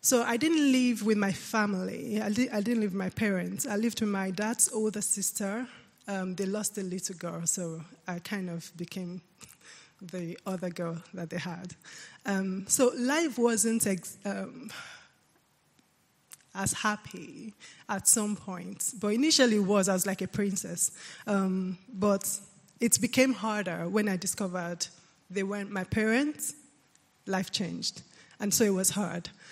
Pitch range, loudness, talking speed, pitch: 185-220 Hz, -29 LUFS, 160 wpm, 200 Hz